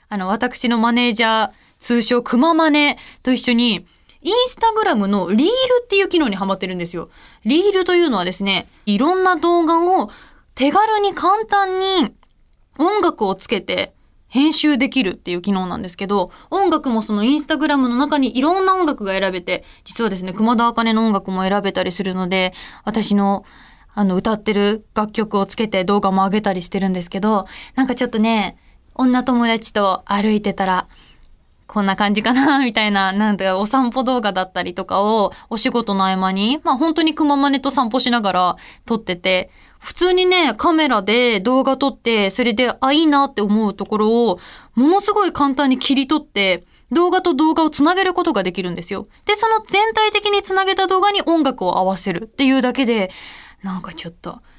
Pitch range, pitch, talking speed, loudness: 200-310 Hz, 235 Hz, 355 characters per minute, -17 LUFS